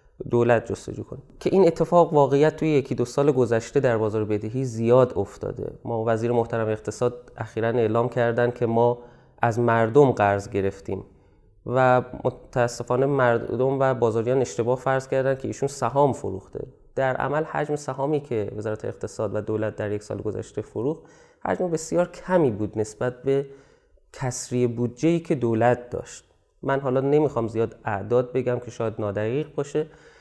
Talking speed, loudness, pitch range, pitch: 155 wpm, -24 LUFS, 115-135 Hz, 120 Hz